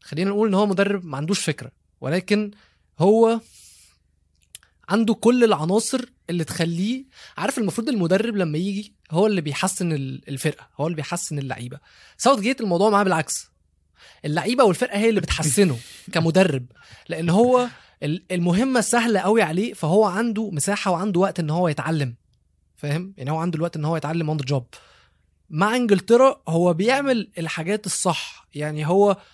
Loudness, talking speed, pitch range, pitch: -21 LUFS, 145 wpm, 150-210 Hz, 180 Hz